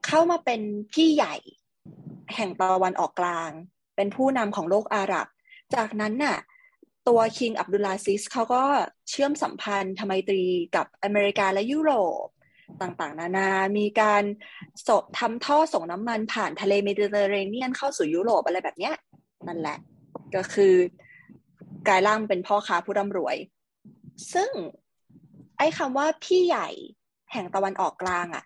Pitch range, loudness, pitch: 190-260 Hz, -25 LUFS, 205 Hz